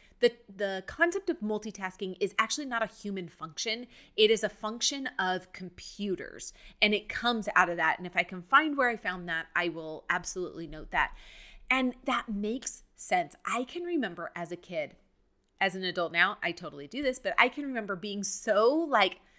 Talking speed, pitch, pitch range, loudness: 190 wpm, 205 Hz, 180-240 Hz, -30 LUFS